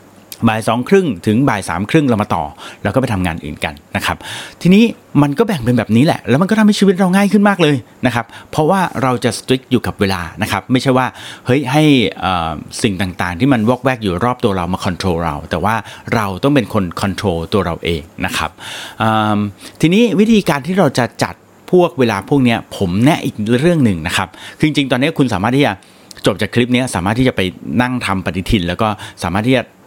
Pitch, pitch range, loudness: 115 Hz, 95-135 Hz, -15 LUFS